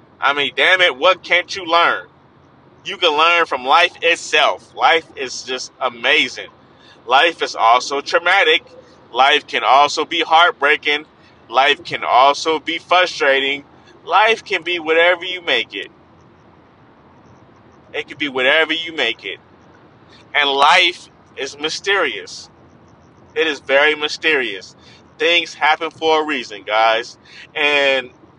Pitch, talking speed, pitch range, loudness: 160 Hz, 130 wpm, 140-175 Hz, -15 LUFS